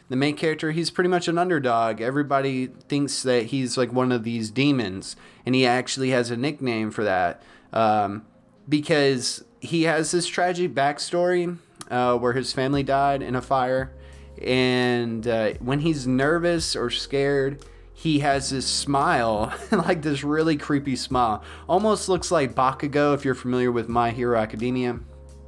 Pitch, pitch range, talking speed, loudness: 130 Hz, 120-150 Hz, 160 wpm, -23 LUFS